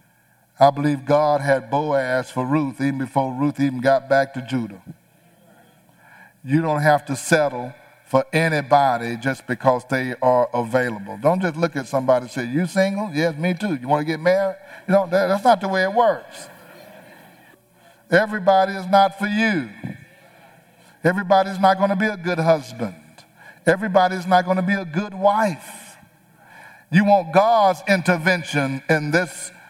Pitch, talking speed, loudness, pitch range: 160 Hz, 160 wpm, -20 LUFS, 135-190 Hz